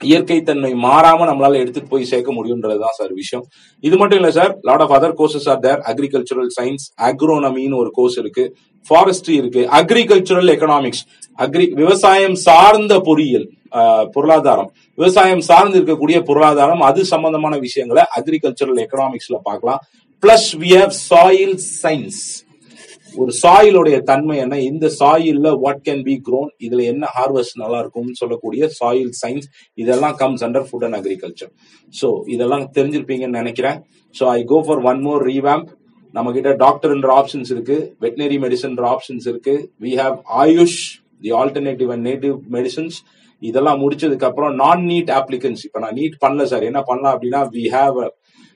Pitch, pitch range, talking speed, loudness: 140 Hz, 130-170 Hz, 135 wpm, -14 LUFS